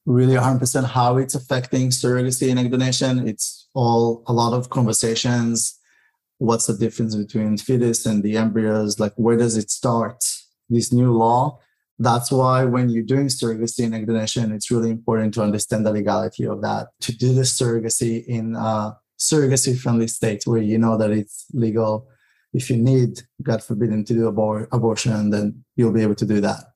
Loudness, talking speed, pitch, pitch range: -20 LUFS, 175 wpm, 115 Hz, 110-125 Hz